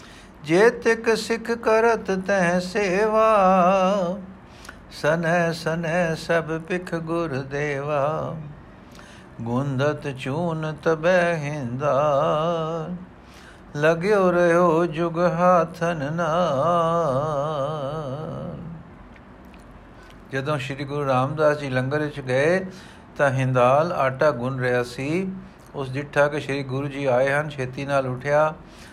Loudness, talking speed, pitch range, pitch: -22 LUFS, 95 wpm, 140-175 Hz, 155 Hz